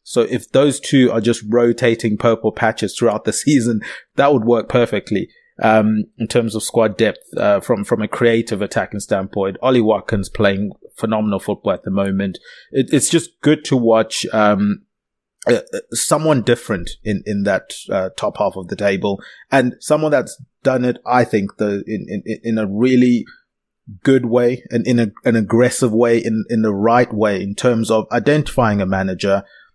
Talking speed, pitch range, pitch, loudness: 180 wpm, 105-125 Hz, 115 Hz, -17 LUFS